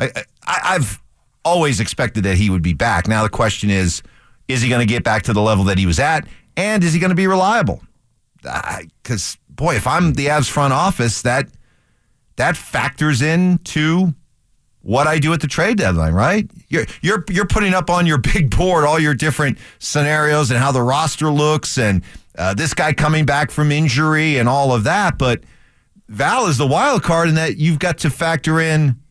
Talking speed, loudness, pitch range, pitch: 200 wpm, -16 LUFS, 120-160 Hz, 150 Hz